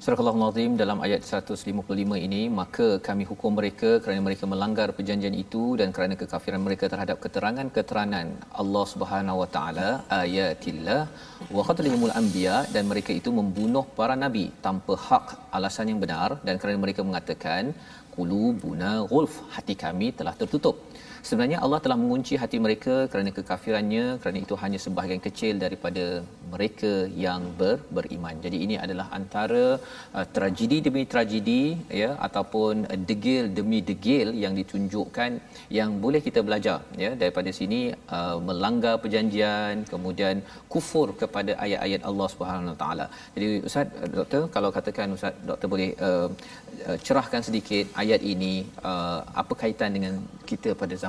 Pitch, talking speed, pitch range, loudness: 105 Hz, 140 wpm, 95-115 Hz, -27 LUFS